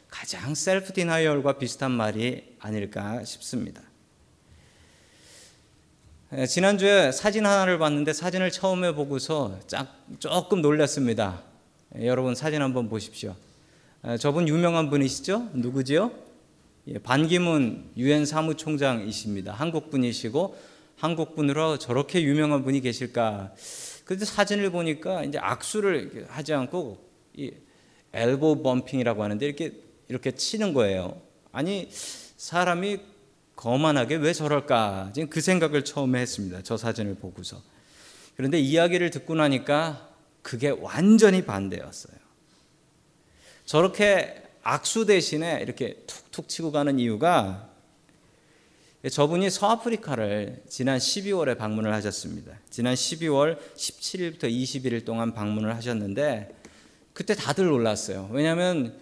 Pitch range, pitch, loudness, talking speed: 120-165 Hz, 145 Hz, -25 LUFS, 275 characters per minute